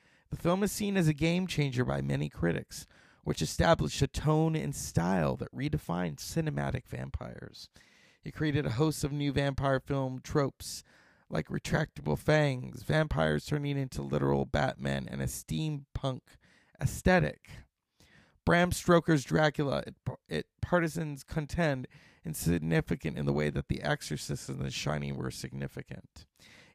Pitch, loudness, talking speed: 135 Hz, -32 LUFS, 135 wpm